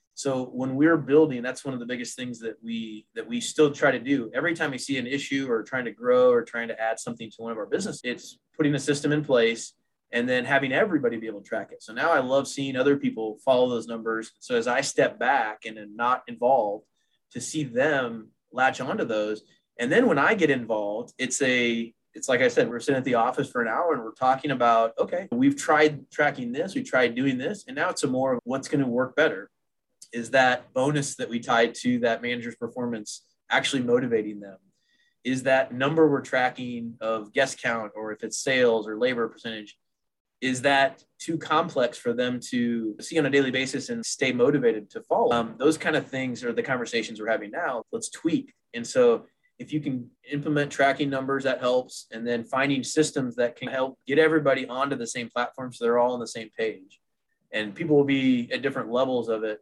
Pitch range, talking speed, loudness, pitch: 115-150 Hz, 220 wpm, -25 LUFS, 130 Hz